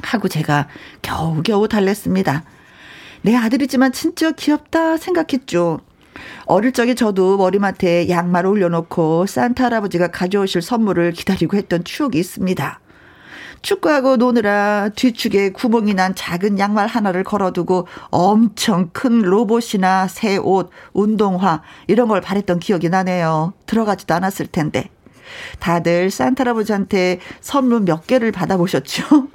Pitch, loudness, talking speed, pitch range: 195 Hz, -17 LUFS, 310 characters per minute, 175-235 Hz